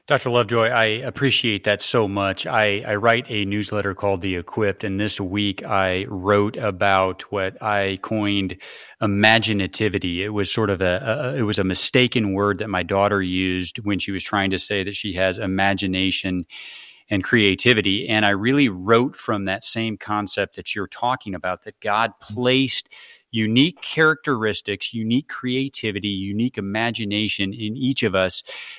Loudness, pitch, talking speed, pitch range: -21 LUFS, 105 Hz, 160 wpm, 95-115 Hz